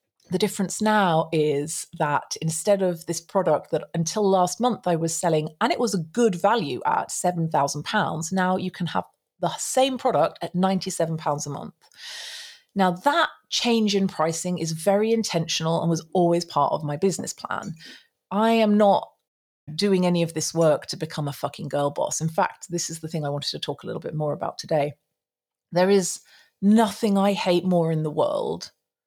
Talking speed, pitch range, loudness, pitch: 185 wpm, 160-200 Hz, -24 LUFS, 175 Hz